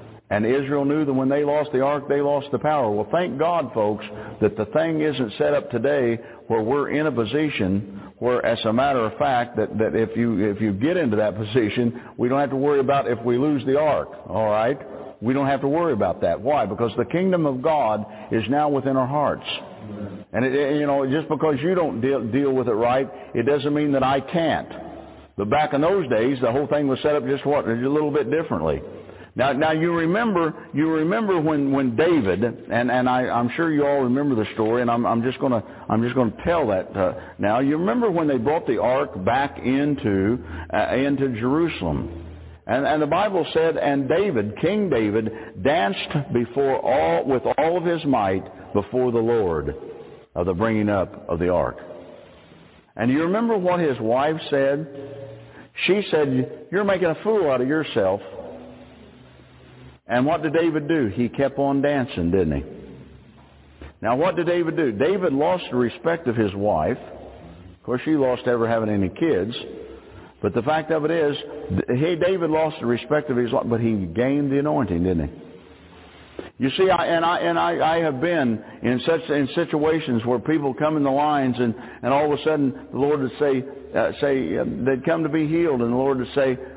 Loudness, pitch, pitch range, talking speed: -22 LUFS, 135 Hz, 115-150 Hz, 205 wpm